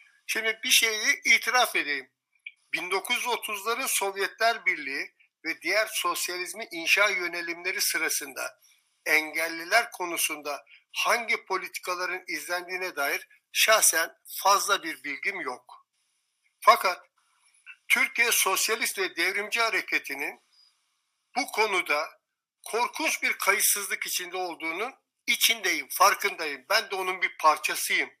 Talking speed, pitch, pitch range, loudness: 95 wpm, 205 Hz, 180-240 Hz, -25 LUFS